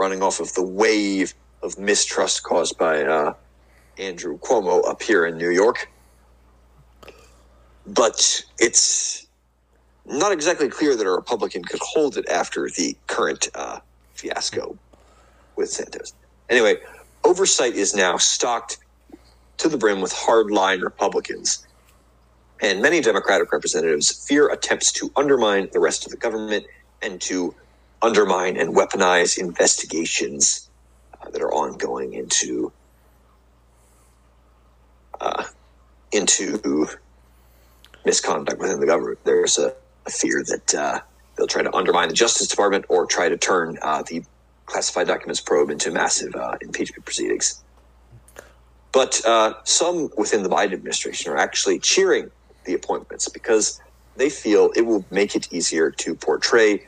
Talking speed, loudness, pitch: 130 wpm, -20 LUFS, 110 Hz